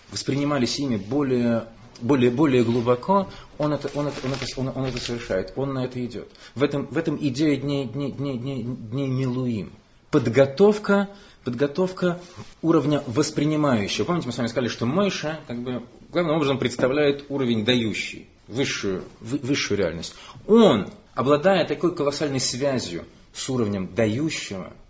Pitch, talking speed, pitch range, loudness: 135 Hz, 135 wpm, 120-150 Hz, -24 LUFS